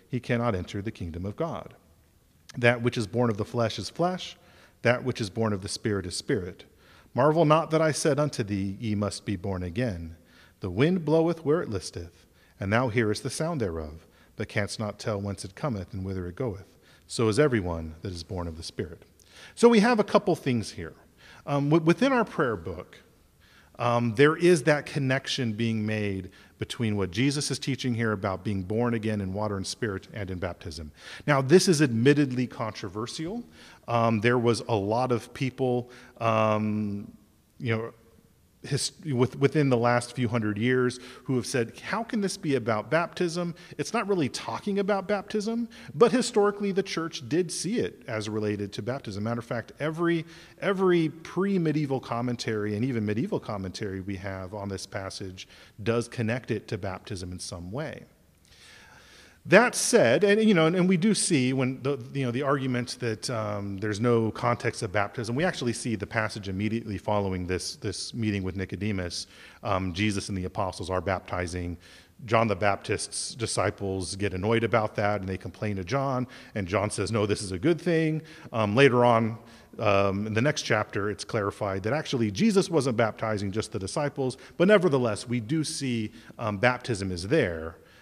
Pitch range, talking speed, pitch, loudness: 100-140 Hz, 180 wpm, 115 Hz, -27 LUFS